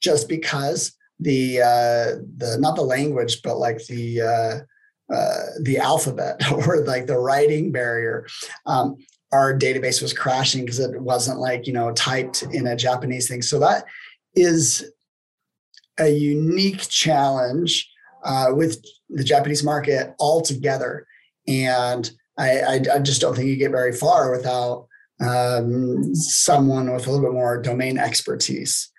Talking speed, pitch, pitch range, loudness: 145 wpm, 130 Hz, 125-150 Hz, -20 LUFS